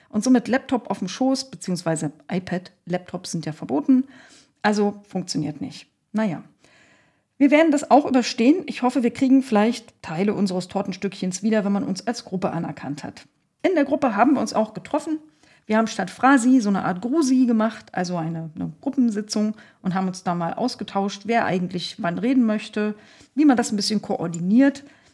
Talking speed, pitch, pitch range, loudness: 180 wpm, 215 Hz, 185-255 Hz, -22 LUFS